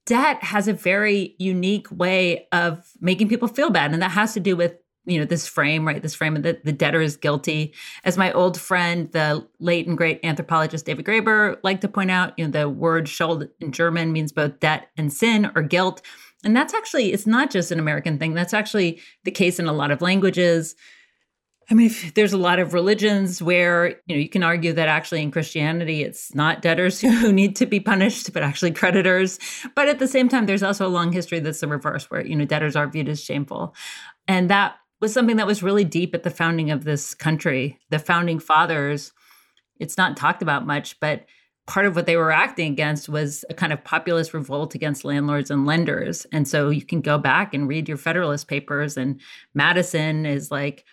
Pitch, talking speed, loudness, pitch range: 170 Hz, 215 wpm, -21 LUFS, 155-190 Hz